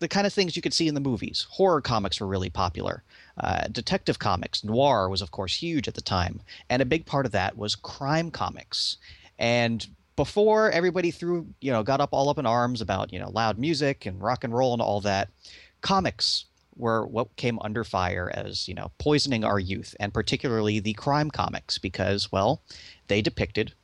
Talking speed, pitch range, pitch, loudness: 200 wpm, 100-140 Hz, 115 Hz, -26 LUFS